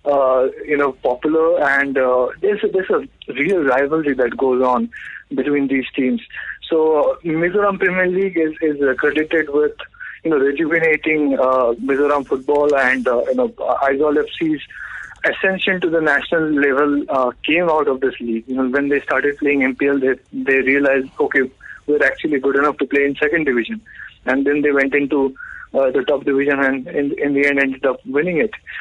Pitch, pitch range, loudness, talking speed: 140 Hz, 135-155 Hz, -17 LUFS, 185 wpm